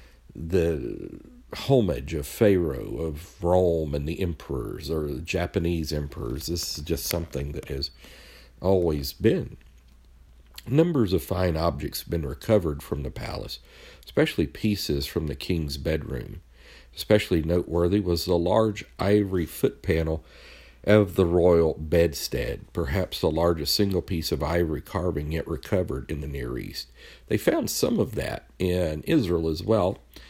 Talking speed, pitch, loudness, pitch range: 145 wpm, 85 Hz, -26 LUFS, 75-95 Hz